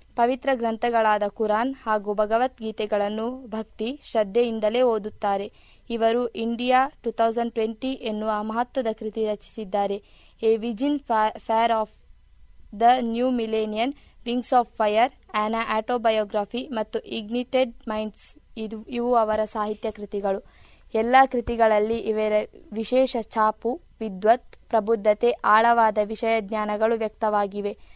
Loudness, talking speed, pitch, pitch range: -24 LUFS, 105 wpm, 225 Hz, 215-240 Hz